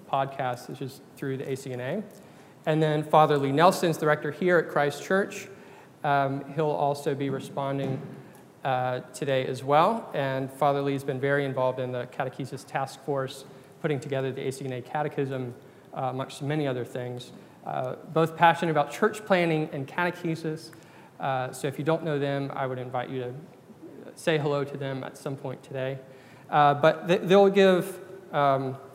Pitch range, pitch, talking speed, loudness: 135-160 Hz, 140 Hz, 170 wpm, -27 LUFS